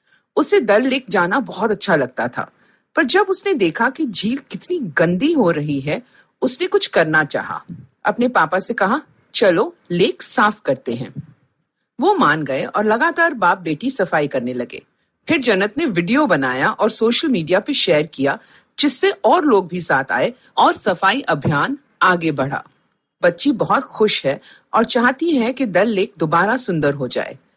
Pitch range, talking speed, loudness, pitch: 175-275 Hz, 170 wpm, -17 LUFS, 215 Hz